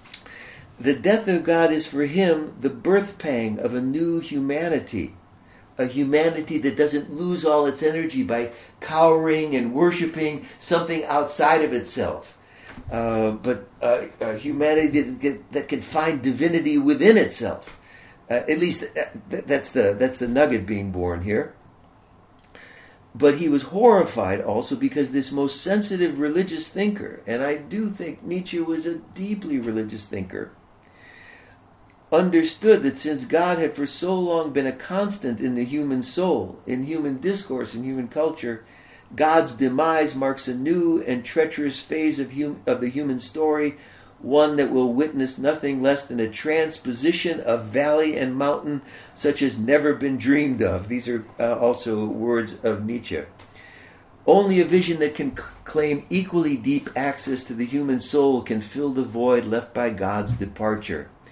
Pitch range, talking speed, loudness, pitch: 125-160 Hz, 155 wpm, -23 LUFS, 145 Hz